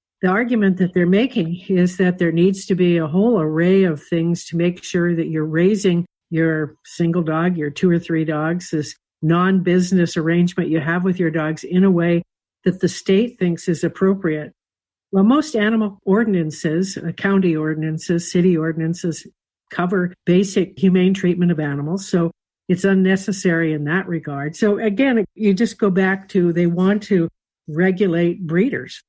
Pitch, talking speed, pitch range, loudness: 180 Hz, 165 wpm, 165-190 Hz, -18 LUFS